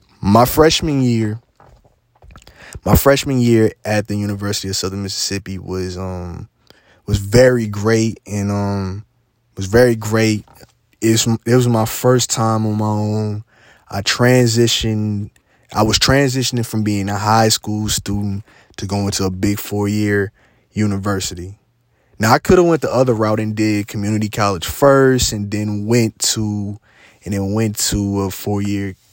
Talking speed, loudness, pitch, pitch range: 150 wpm, -16 LUFS, 105 Hz, 100-115 Hz